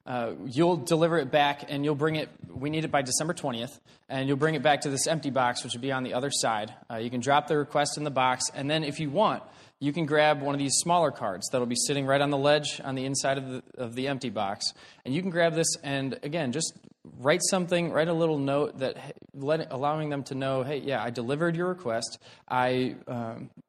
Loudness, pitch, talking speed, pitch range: -28 LUFS, 140 Hz, 245 wpm, 130-155 Hz